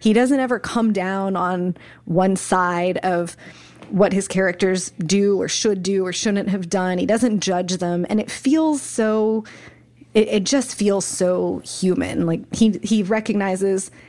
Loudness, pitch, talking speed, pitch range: -20 LUFS, 195 Hz, 160 wpm, 185-220 Hz